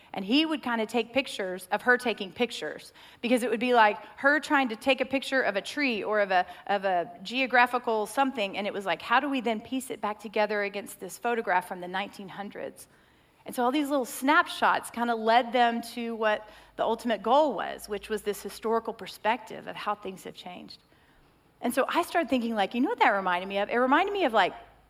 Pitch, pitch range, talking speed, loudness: 230 Hz, 205-260 Hz, 225 wpm, -27 LUFS